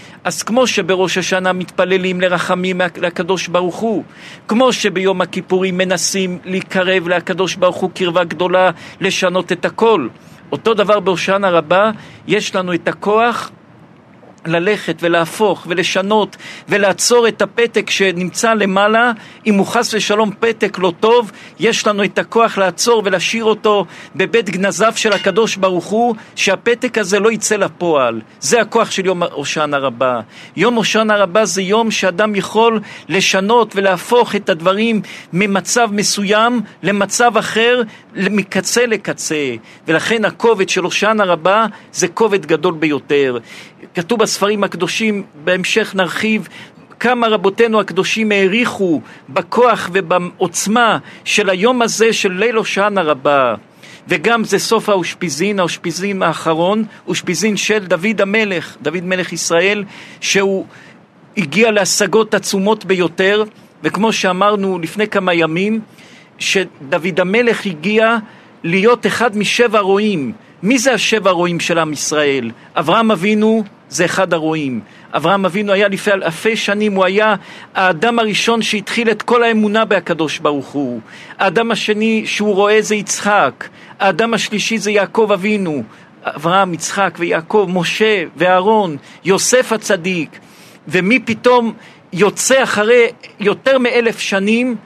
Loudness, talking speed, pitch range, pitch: -14 LUFS, 125 wpm, 180-220 Hz, 195 Hz